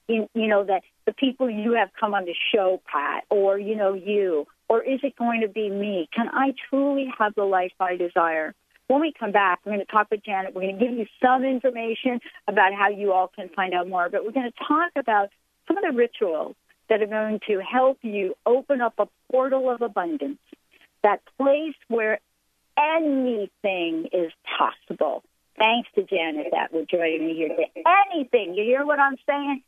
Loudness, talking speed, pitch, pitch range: -24 LUFS, 200 wpm, 220 Hz, 195-265 Hz